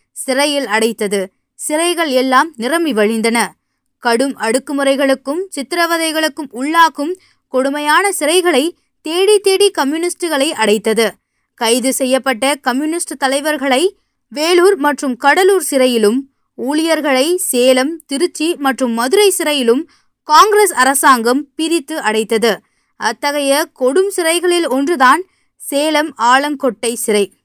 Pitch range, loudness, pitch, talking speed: 255-330 Hz, -14 LUFS, 285 Hz, 90 wpm